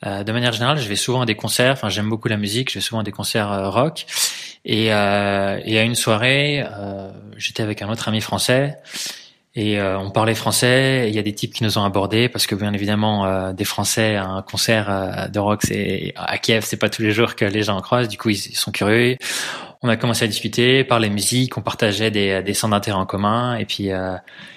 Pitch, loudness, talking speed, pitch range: 110 Hz, -19 LUFS, 240 wpm, 100-115 Hz